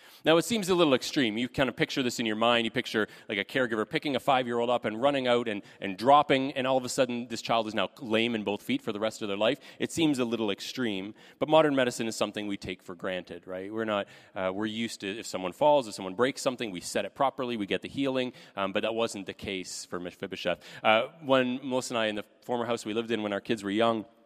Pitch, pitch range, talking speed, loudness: 115 Hz, 105-130 Hz, 275 wpm, -29 LUFS